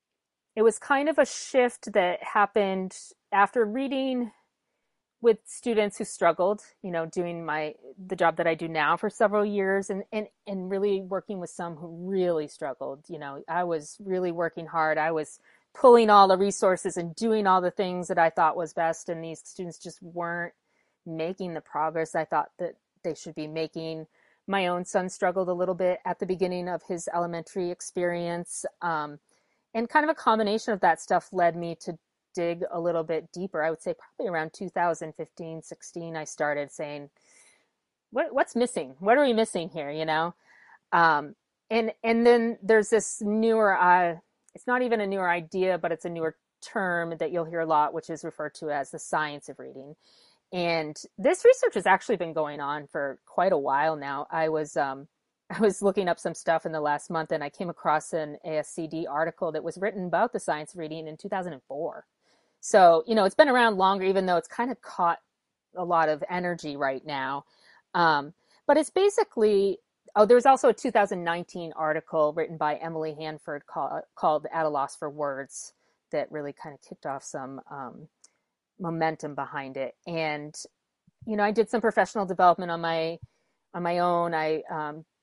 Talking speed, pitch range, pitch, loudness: 195 wpm, 160-205 Hz, 175 Hz, -26 LUFS